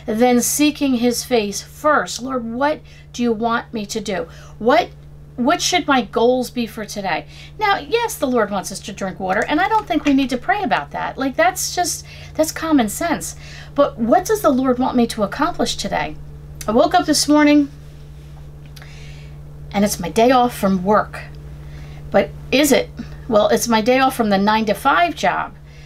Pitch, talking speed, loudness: 230 Hz, 190 wpm, -18 LUFS